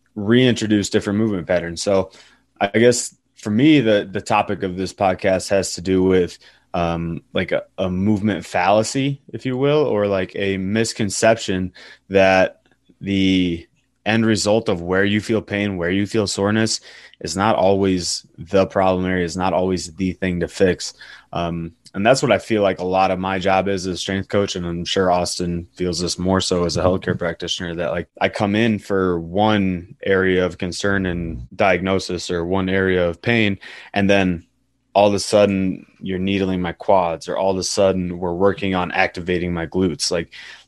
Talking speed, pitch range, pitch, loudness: 185 wpm, 90-105 Hz, 95 Hz, -19 LUFS